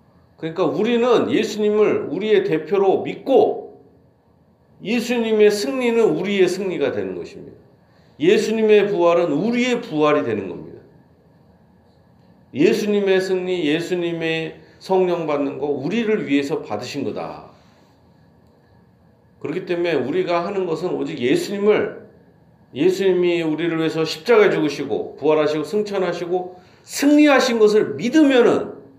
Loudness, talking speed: -19 LUFS, 285 characters per minute